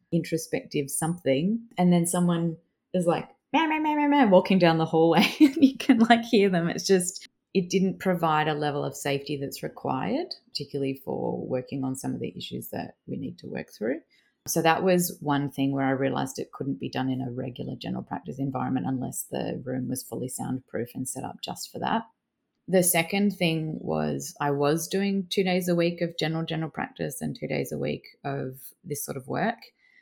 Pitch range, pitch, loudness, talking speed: 145-190 Hz, 170 Hz, -26 LUFS, 200 wpm